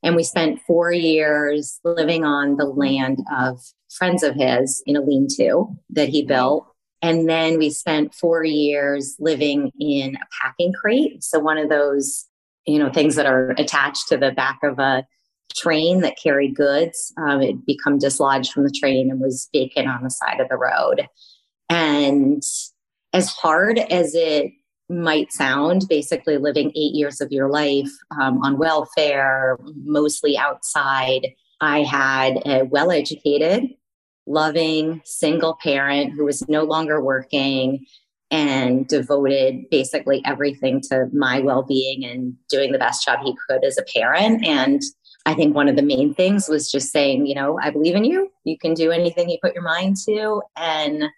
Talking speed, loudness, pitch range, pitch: 165 wpm, -19 LUFS, 140-165 Hz, 150 Hz